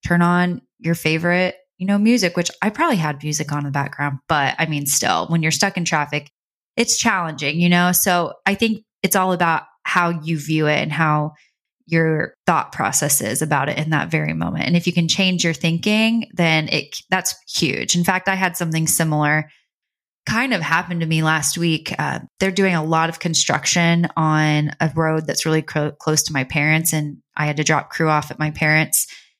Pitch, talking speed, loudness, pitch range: 165 Hz, 205 wpm, -19 LUFS, 155-180 Hz